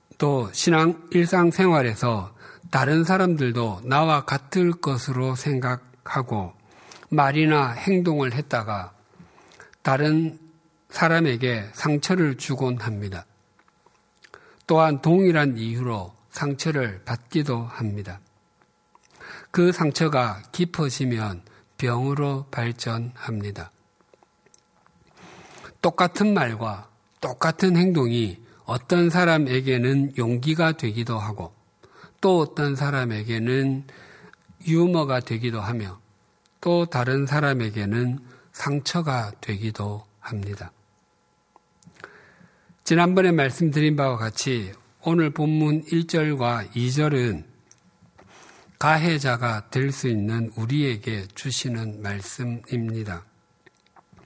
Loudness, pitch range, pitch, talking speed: -23 LUFS, 115-155 Hz, 130 Hz, 200 characters per minute